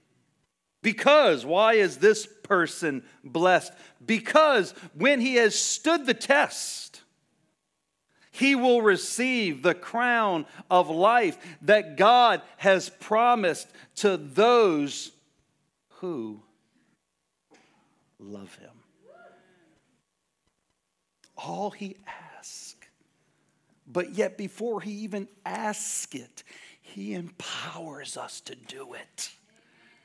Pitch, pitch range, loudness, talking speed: 205 Hz, 170-230 Hz, -24 LUFS, 90 wpm